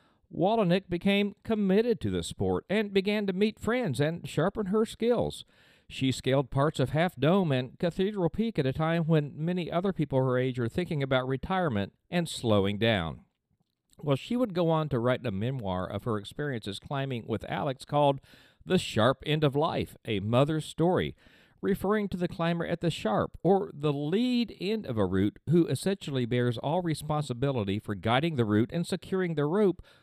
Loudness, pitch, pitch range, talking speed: -29 LUFS, 150 Hz, 125-185 Hz, 180 wpm